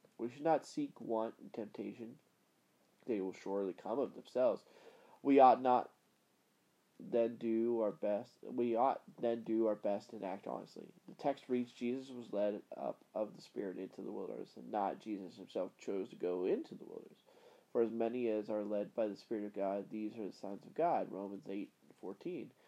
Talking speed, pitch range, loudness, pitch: 195 wpm, 105-125 Hz, -38 LUFS, 115 Hz